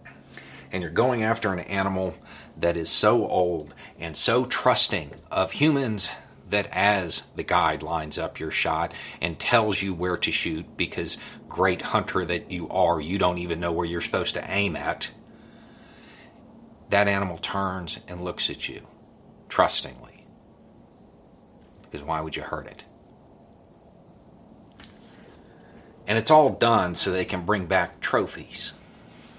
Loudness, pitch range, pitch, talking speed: -25 LUFS, 85-105 Hz, 95 Hz, 140 wpm